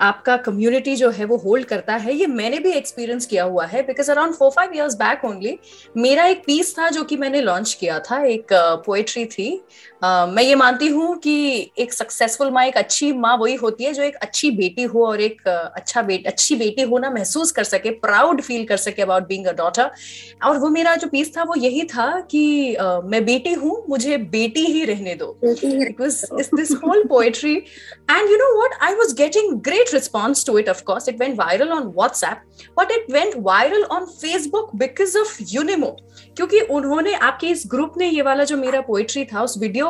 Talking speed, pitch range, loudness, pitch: 200 wpm, 225-315 Hz, -18 LUFS, 270 Hz